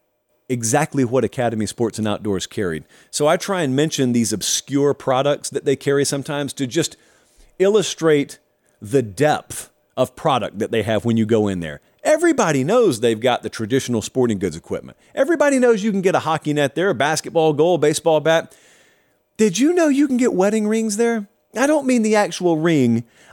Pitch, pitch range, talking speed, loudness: 145 Hz, 120-195 Hz, 190 wpm, -19 LUFS